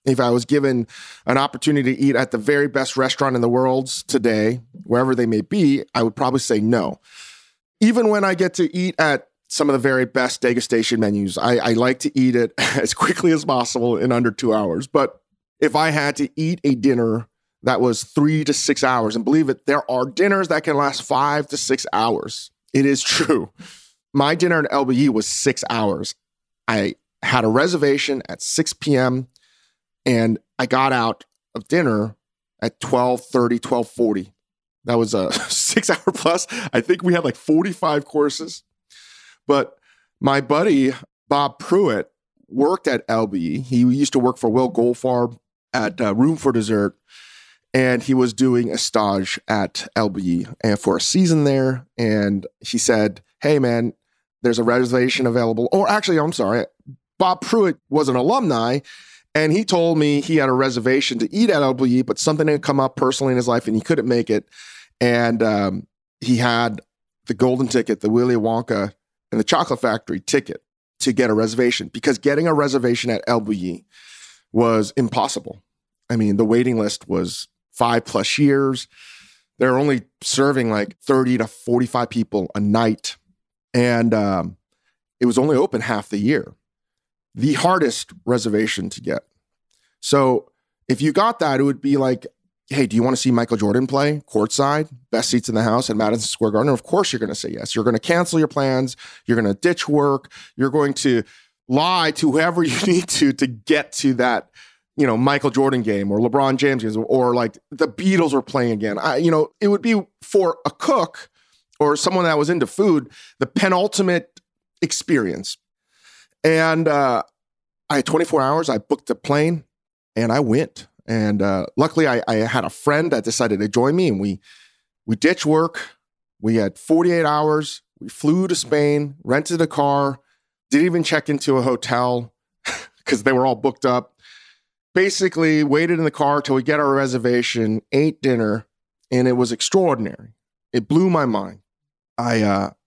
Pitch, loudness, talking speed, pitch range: 130 Hz, -19 LUFS, 180 wpm, 115-150 Hz